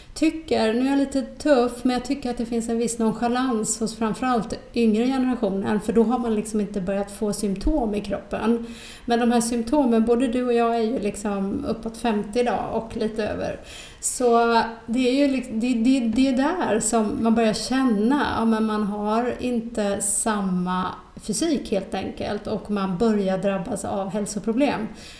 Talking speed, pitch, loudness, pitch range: 180 wpm, 230 Hz, -23 LUFS, 210-245 Hz